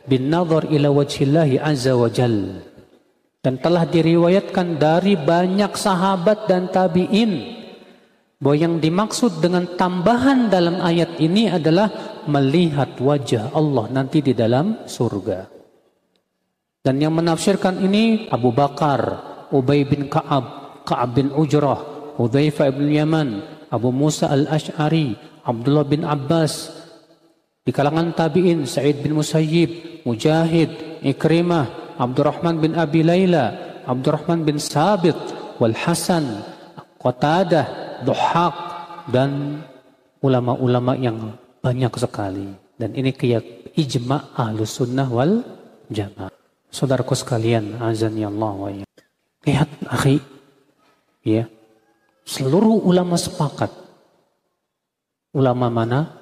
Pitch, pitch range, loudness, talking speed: 150 Hz, 130-170 Hz, -19 LUFS, 105 wpm